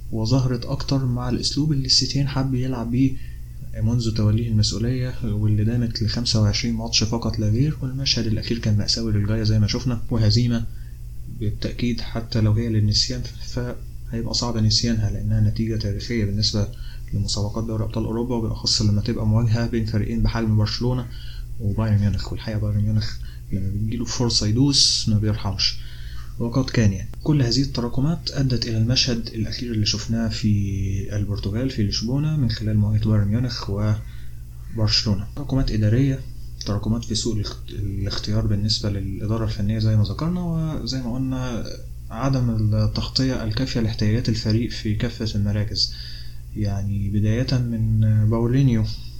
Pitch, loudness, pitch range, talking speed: 110 Hz, -22 LUFS, 105-120 Hz, 140 wpm